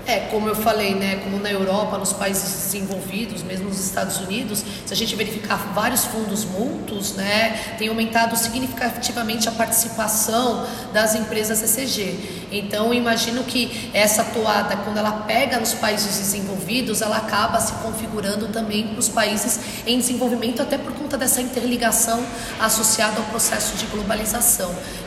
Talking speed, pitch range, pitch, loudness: 145 wpm, 205-230 Hz, 220 Hz, -21 LUFS